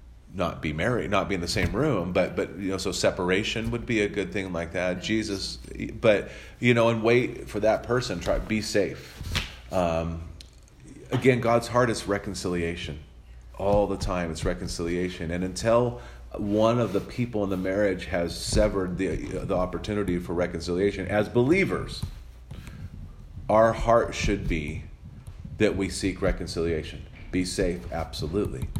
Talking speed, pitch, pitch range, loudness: 155 wpm, 95 Hz, 85-110 Hz, -26 LUFS